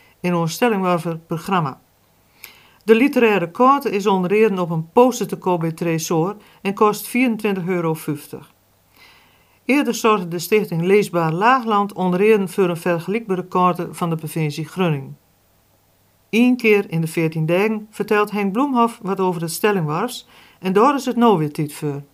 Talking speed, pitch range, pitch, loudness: 155 wpm, 165-215 Hz, 185 Hz, -19 LUFS